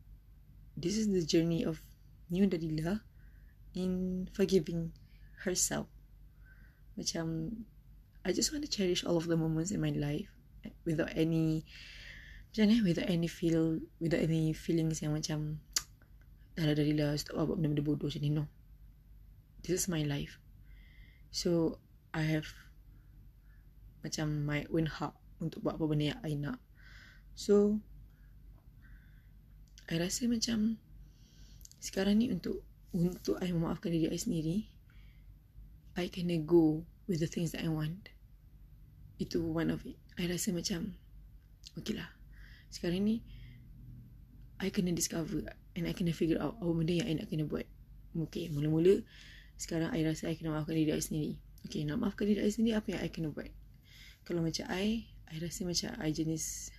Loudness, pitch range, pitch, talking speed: -34 LUFS, 155-185 Hz, 165 Hz, 140 wpm